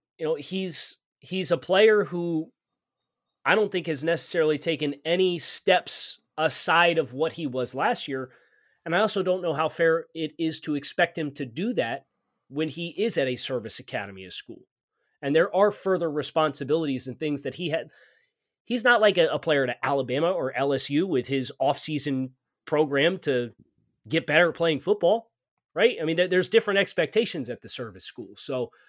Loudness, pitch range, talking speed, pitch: -25 LUFS, 140-180 Hz, 185 wpm, 160 Hz